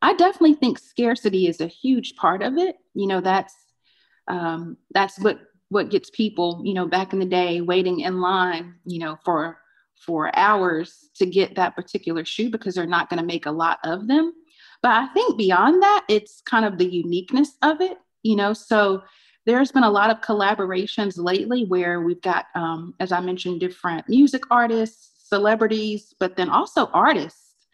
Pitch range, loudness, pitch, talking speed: 180-240 Hz, -21 LUFS, 200 Hz, 185 wpm